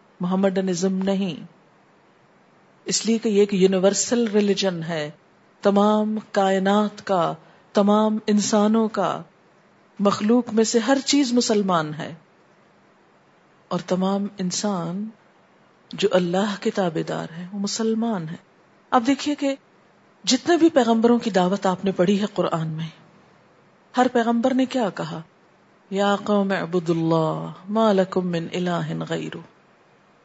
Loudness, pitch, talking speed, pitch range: -22 LUFS, 200 Hz, 125 wpm, 180-220 Hz